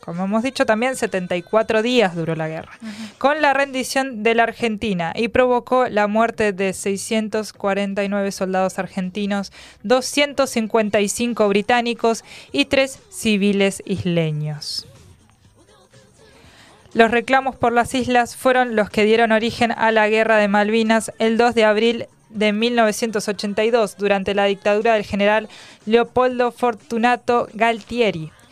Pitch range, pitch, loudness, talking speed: 200-235 Hz, 220 Hz, -19 LUFS, 120 wpm